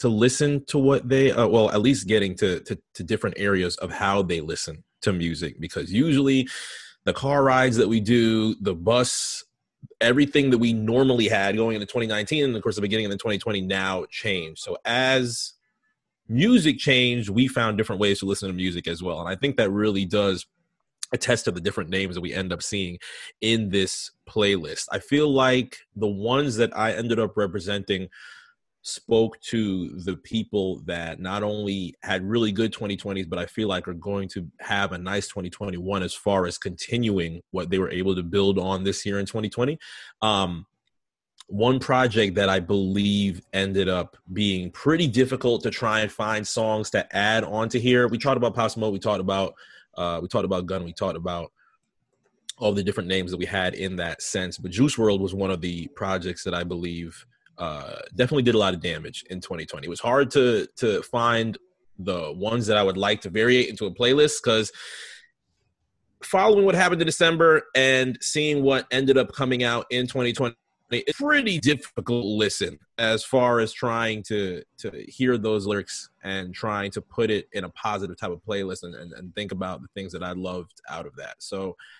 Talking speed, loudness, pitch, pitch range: 195 wpm, -24 LUFS, 105 Hz, 95-120 Hz